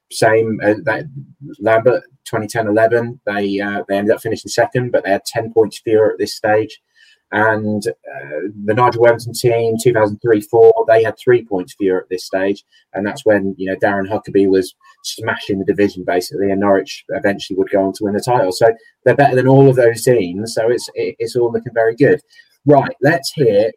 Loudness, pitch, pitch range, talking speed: -15 LUFS, 115 Hz, 100-135 Hz, 190 wpm